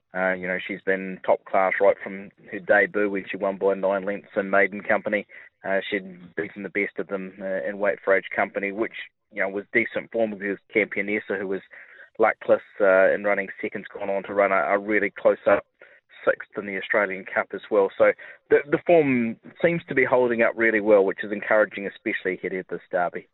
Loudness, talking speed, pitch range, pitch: -24 LUFS, 215 wpm, 95-115 Hz, 100 Hz